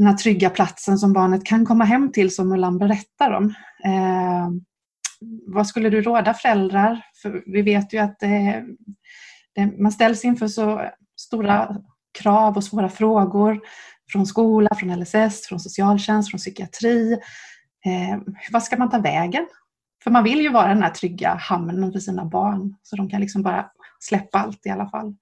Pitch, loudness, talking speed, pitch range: 205 Hz, -20 LUFS, 170 wpm, 195-220 Hz